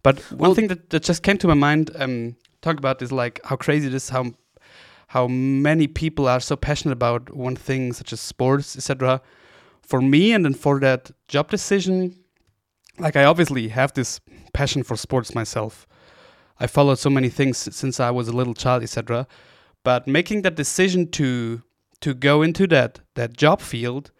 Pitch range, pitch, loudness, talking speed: 125-155 Hz, 135 Hz, -21 LUFS, 185 wpm